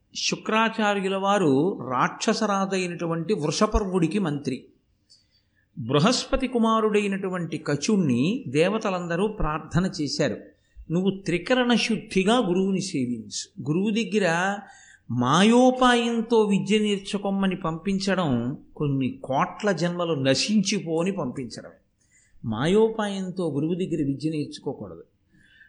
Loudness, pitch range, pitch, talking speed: -24 LUFS, 155-215 Hz, 185 Hz, 75 wpm